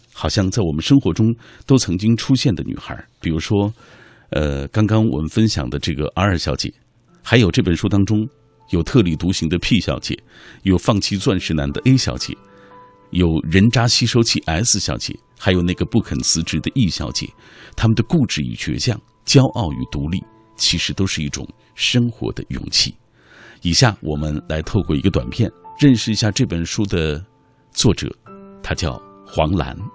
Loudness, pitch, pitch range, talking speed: -18 LUFS, 100 Hz, 80-115 Hz, 255 characters per minute